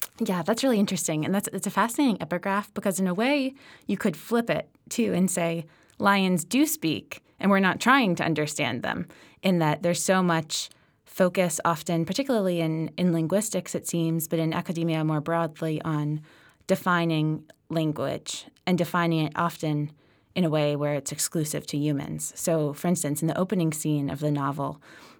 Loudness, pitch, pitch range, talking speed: -26 LUFS, 170 Hz, 155-190 Hz, 175 wpm